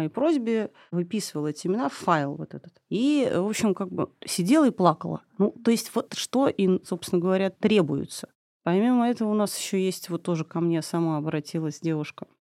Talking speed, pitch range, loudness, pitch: 190 wpm, 170-220 Hz, -26 LUFS, 190 Hz